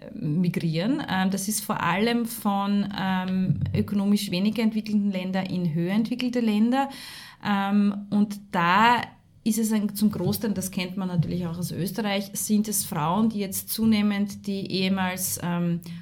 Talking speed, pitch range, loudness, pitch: 140 wpm, 185-215 Hz, -25 LUFS, 200 Hz